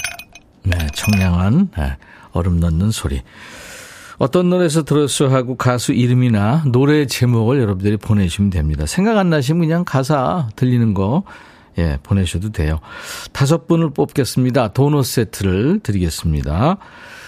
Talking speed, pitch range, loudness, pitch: 300 characters per minute, 95-145 Hz, -17 LUFS, 125 Hz